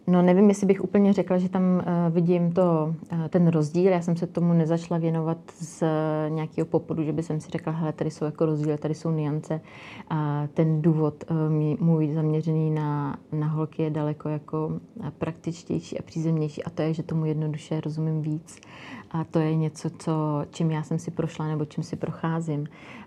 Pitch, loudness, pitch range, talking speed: 160 Hz, -26 LUFS, 155-170 Hz, 175 wpm